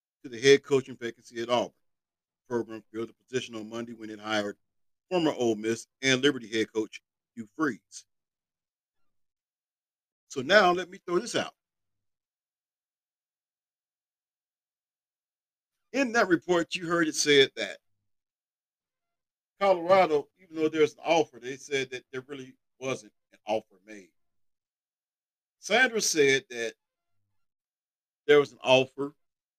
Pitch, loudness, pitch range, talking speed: 130 Hz, -26 LUFS, 110-160 Hz, 130 wpm